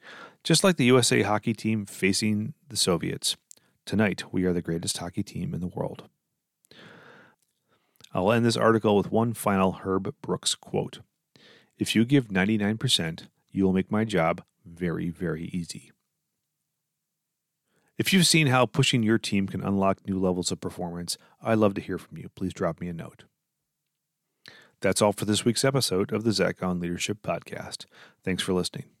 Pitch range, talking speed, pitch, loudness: 95-125 Hz, 165 wpm, 105 Hz, -26 LUFS